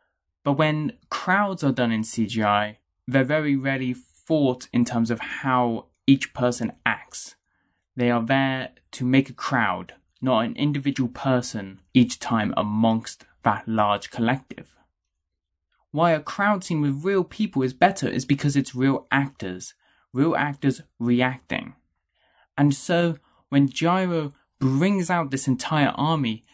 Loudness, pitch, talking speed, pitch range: -23 LUFS, 130 Hz, 140 wpm, 115-145 Hz